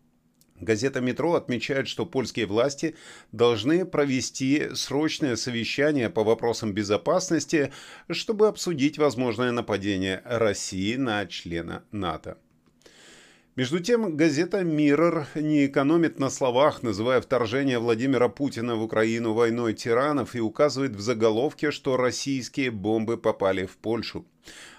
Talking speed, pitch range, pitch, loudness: 115 wpm, 110-150 Hz, 125 Hz, -25 LUFS